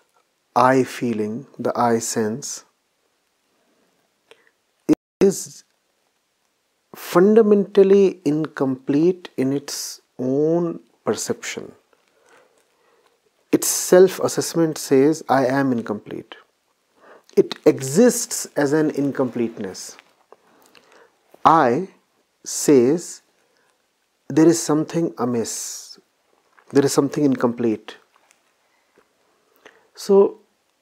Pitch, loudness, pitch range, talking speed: 160 Hz, -19 LUFS, 135-230 Hz, 70 wpm